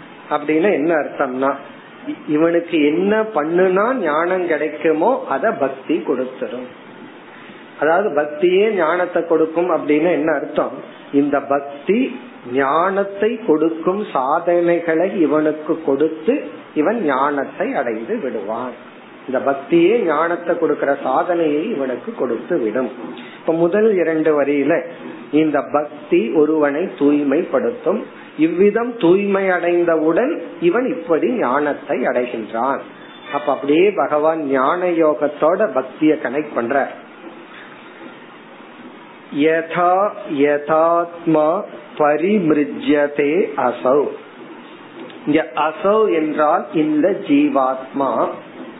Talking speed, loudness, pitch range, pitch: 80 wpm, -18 LUFS, 150-185 Hz, 160 Hz